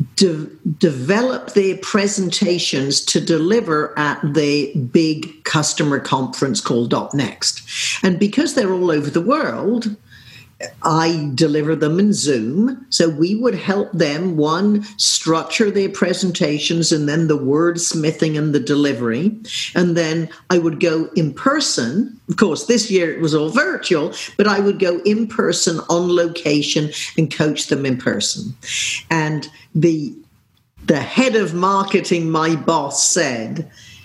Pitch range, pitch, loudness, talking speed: 155-195 Hz, 170 Hz, -17 LUFS, 140 wpm